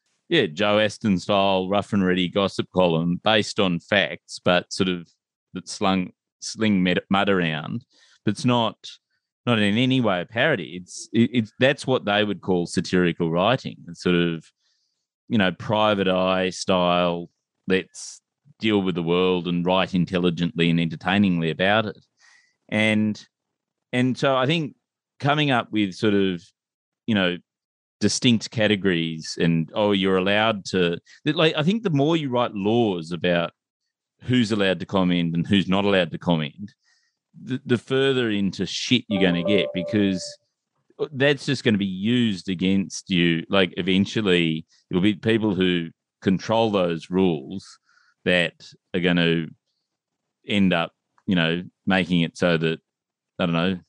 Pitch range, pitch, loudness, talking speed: 90-110 Hz, 95 Hz, -22 LUFS, 155 wpm